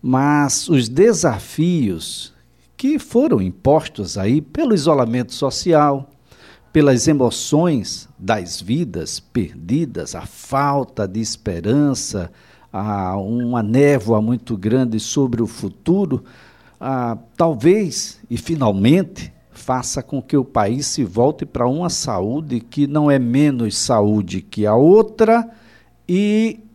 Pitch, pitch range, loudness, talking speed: 130 Hz, 115-155 Hz, -18 LUFS, 110 wpm